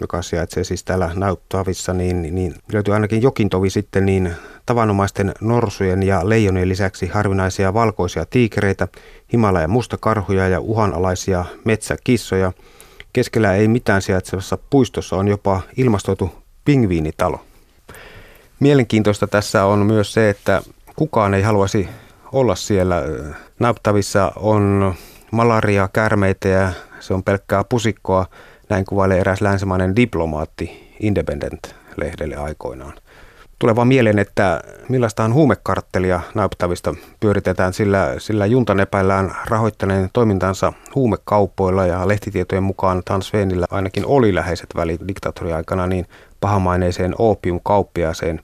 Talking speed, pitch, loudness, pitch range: 110 wpm, 100 Hz, -18 LUFS, 95-110 Hz